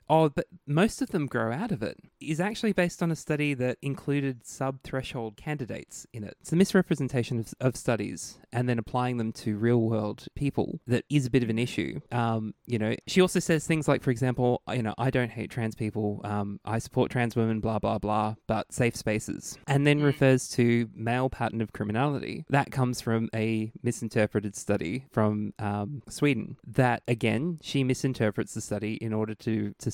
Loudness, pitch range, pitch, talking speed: -28 LUFS, 110-140 Hz, 120 Hz, 195 wpm